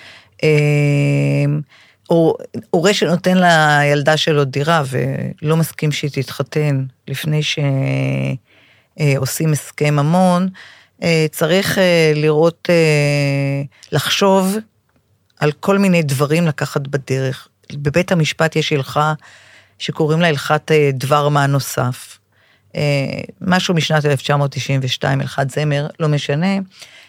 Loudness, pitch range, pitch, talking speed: -16 LUFS, 140-165 Hz, 150 Hz, 95 wpm